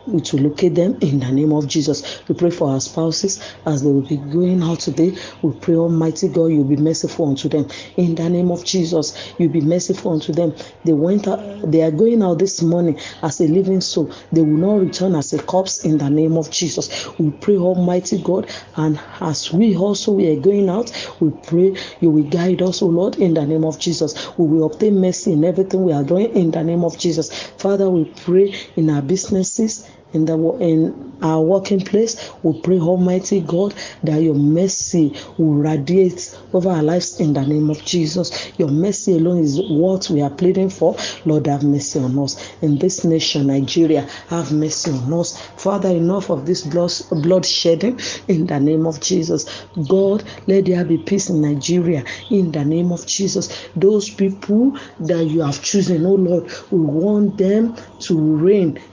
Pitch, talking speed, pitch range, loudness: 170 Hz, 195 wpm, 155-185 Hz, -17 LUFS